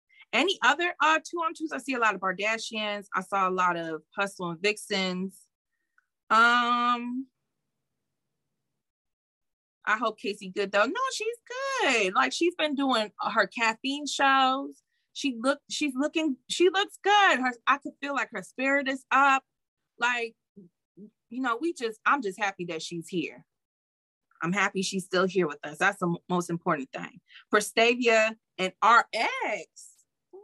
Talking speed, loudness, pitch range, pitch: 160 wpm, -26 LUFS, 190-280 Hz, 225 Hz